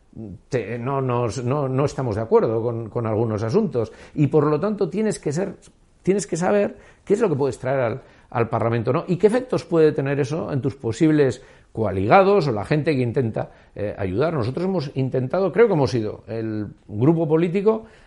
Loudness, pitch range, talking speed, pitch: -22 LUFS, 120-175 Hz, 195 wpm, 140 Hz